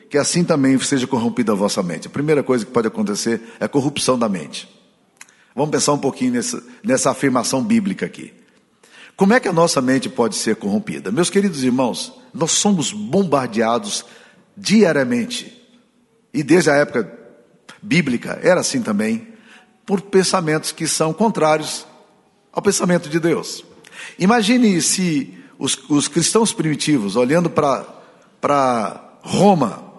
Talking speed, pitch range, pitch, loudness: 140 wpm, 145-225 Hz, 180 Hz, -18 LUFS